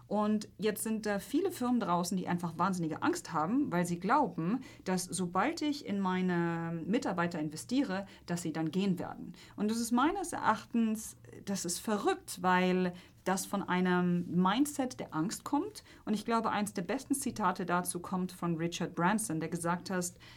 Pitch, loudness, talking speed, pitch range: 190 Hz, -33 LUFS, 170 wpm, 175-230 Hz